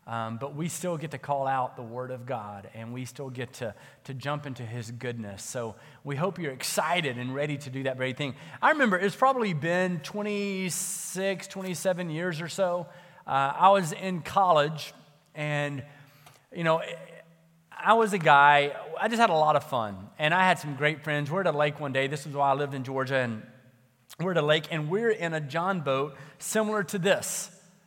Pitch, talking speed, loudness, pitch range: 150 Hz, 205 wpm, -27 LUFS, 135-180 Hz